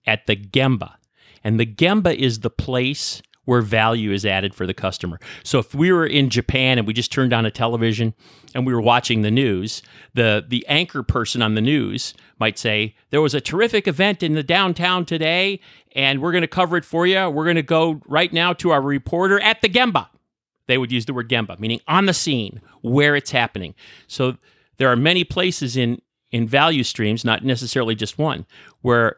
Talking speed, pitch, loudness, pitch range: 205 wpm, 130 Hz, -19 LUFS, 115-160 Hz